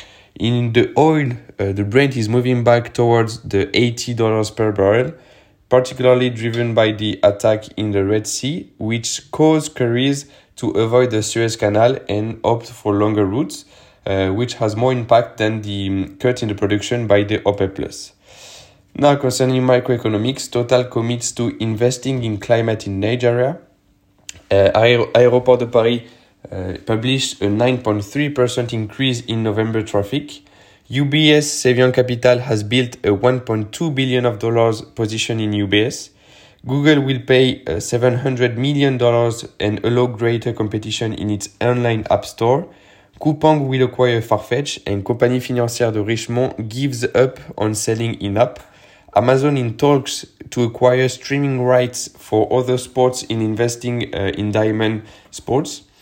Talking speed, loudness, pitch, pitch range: 140 wpm, -17 LUFS, 120 Hz, 105-125 Hz